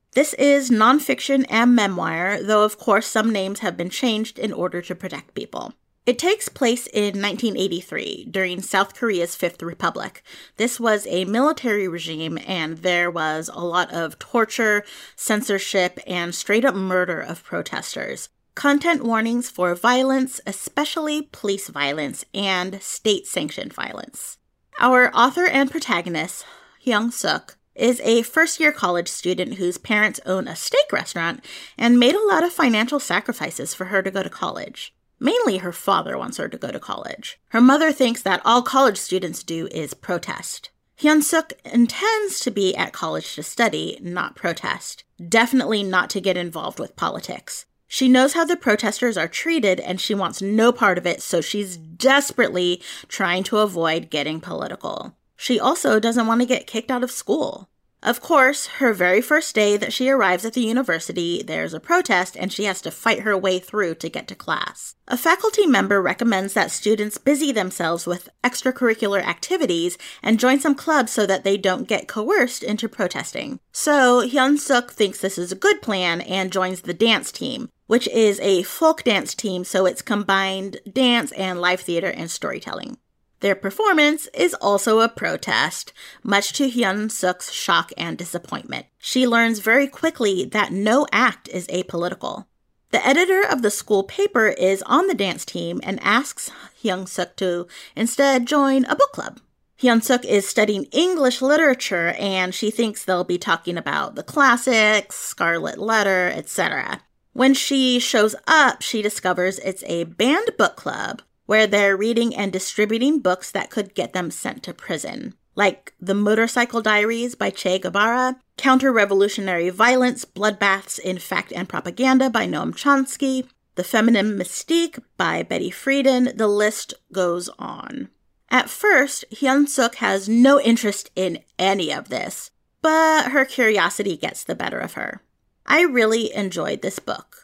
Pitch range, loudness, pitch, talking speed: 185-255 Hz, -20 LUFS, 215 Hz, 160 wpm